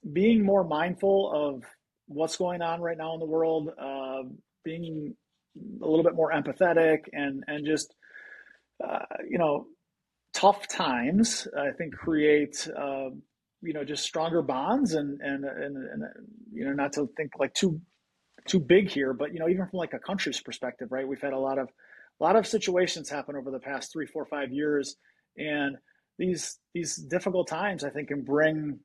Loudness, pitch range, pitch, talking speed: -28 LUFS, 140-180 Hz, 160 Hz, 180 wpm